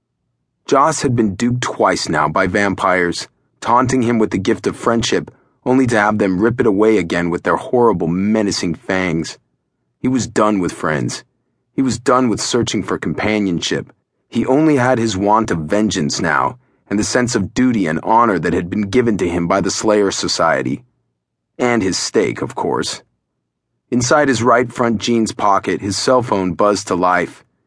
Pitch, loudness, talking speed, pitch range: 105 Hz, -16 LUFS, 180 wpm, 95-120 Hz